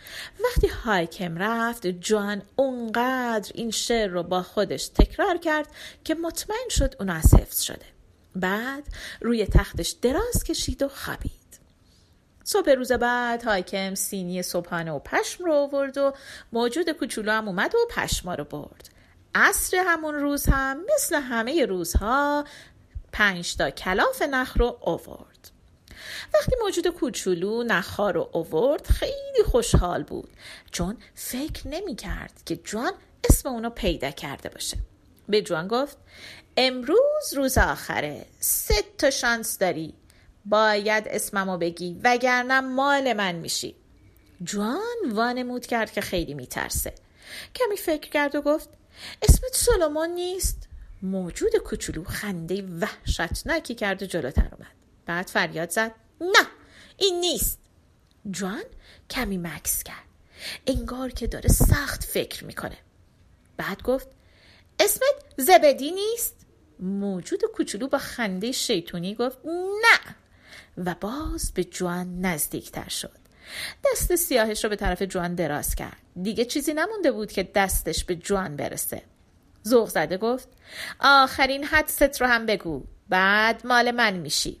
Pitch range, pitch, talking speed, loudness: 190-300 Hz, 235 Hz, 125 wpm, -25 LUFS